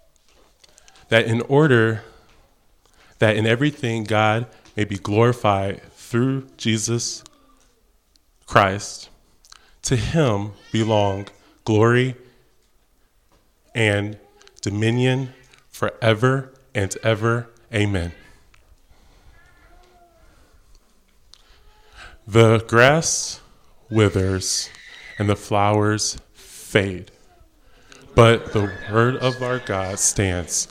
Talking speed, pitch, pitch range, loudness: 70 wpm, 110 Hz, 100-120 Hz, -20 LUFS